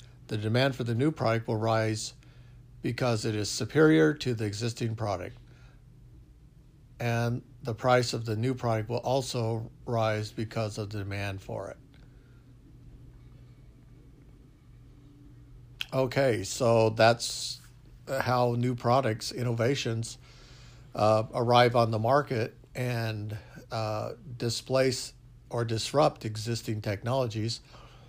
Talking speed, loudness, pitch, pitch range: 110 wpm, -29 LUFS, 125 Hz, 115-130 Hz